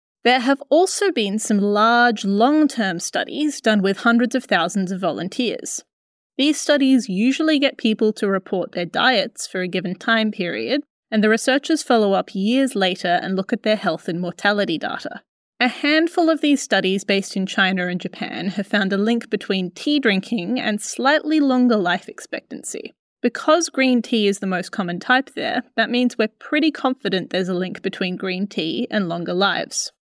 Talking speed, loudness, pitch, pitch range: 180 wpm, -20 LUFS, 220 Hz, 195-260 Hz